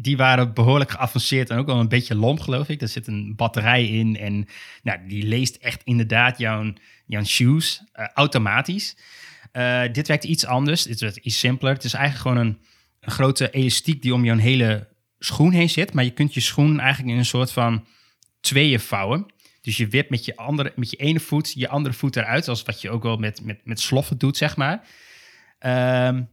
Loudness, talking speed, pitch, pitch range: -21 LUFS, 205 wpm, 125 Hz, 115-140 Hz